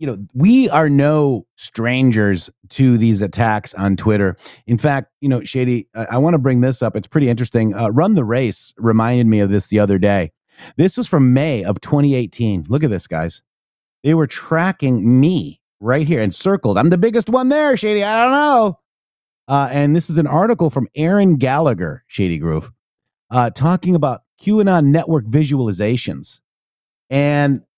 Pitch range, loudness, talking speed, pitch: 110-160 Hz, -16 LUFS, 175 wpm, 130 Hz